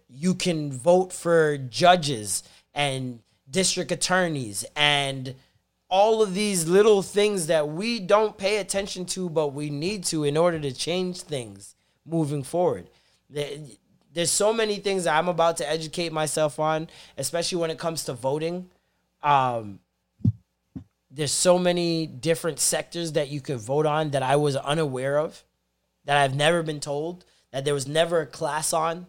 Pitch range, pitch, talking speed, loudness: 145-175 Hz, 160 Hz, 155 wpm, -24 LUFS